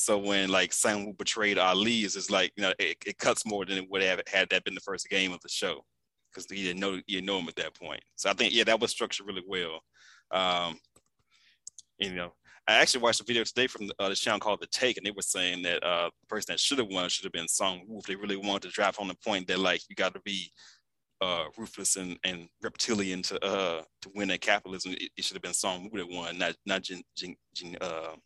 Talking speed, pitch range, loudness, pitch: 255 wpm, 90-100 Hz, -29 LUFS, 95 Hz